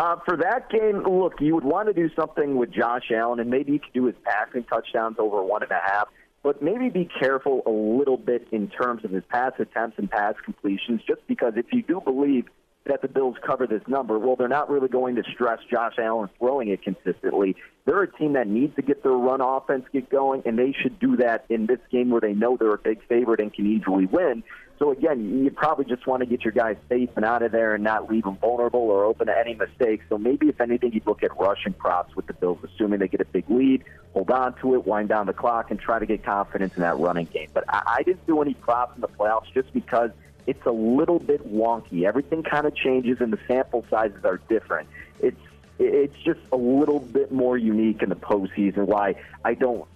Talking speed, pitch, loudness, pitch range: 240 wpm, 125 Hz, -24 LUFS, 110-140 Hz